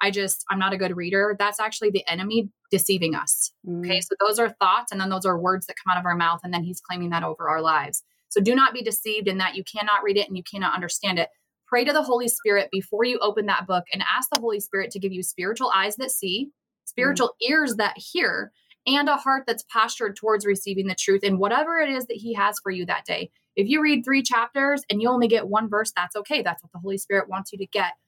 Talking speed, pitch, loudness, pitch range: 260 wpm, 205 Hz, -23 LUFS, 190-235 Hz